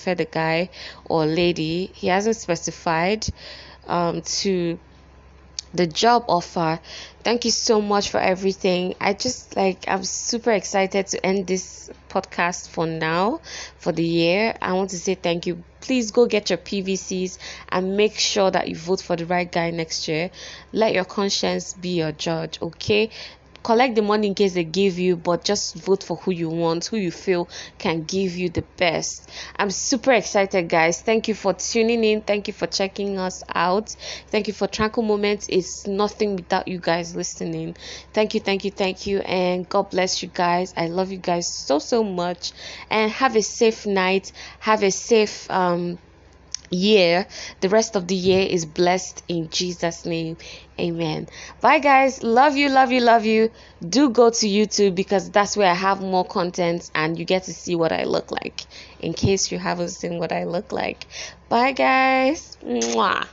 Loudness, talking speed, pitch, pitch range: -22 LUFS, 180 wpm, 185 Hz, 175-210 Hz